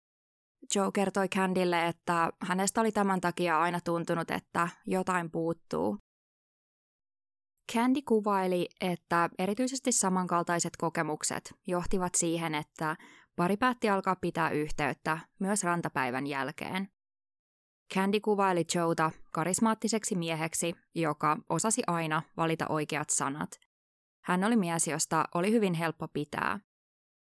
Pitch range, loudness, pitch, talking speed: 155-195 Hz, -30 LUFS, 170 Hz, 110 wpm